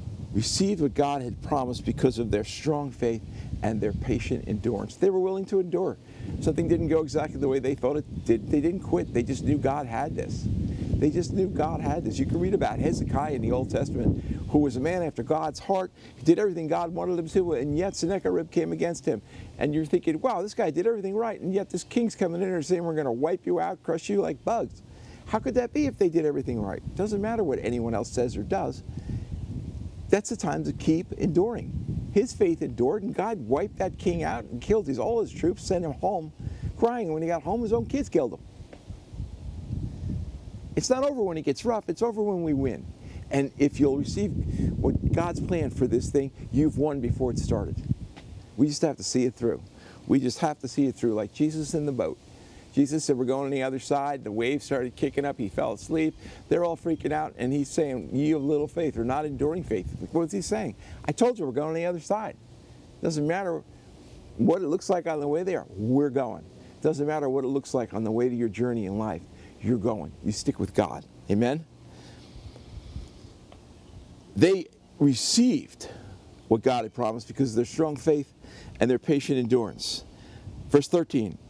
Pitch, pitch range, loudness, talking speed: 140 Hz, 120-170 Hz, -27 LUFS, 215 wpm